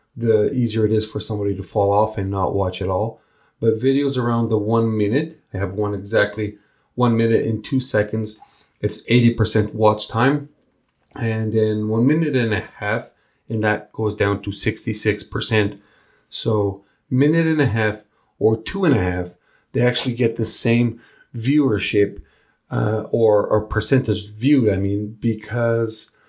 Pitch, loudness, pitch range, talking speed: 110 Hz, -20 LUFS, 105-120 Hz, 160 wpm